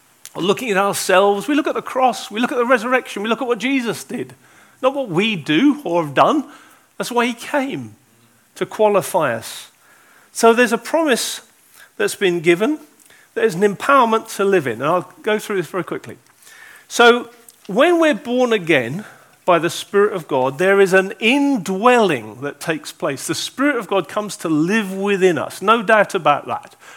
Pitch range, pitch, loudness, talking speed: 185-255 Hz, 215 Hz, -17 LUFS, 185 wpm